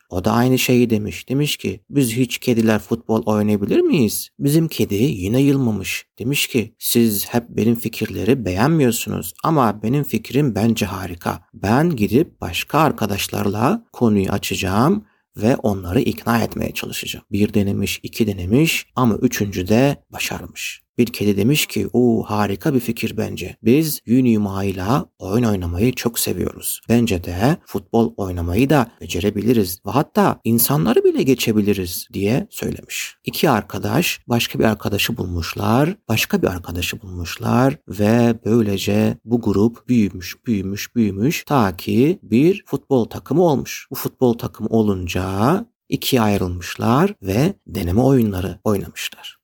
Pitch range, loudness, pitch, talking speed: 100-125 Hz, -19 LUFS, 115 Hz, 135 wpm